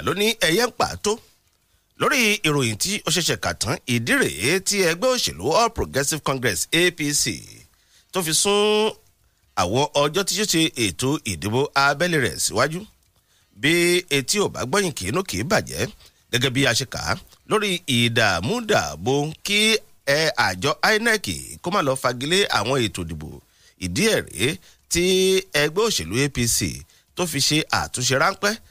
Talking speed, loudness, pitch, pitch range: 155 wpm, -21 LUFS, 145 Hz, 120-190 Hz